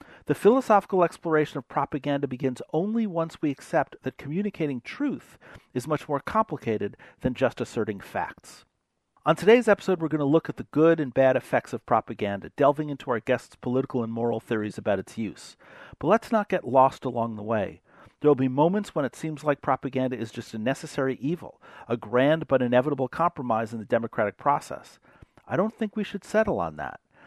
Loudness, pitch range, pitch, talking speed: -26 LUFS, 125-165 Hz, 145 Hz, 190 wpm